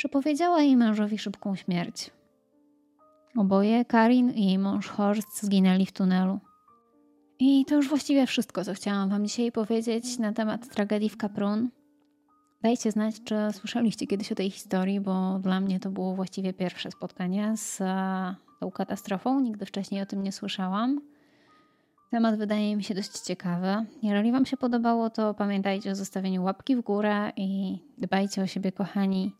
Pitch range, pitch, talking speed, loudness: 195-240 Hz, 210 Hz, 155 wpm, -27 LUFS